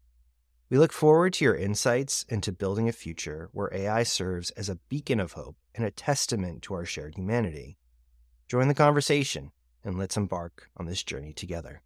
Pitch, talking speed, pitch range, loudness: 95 Hz, 175 wpm, 75-120 Hz, -28 LUFS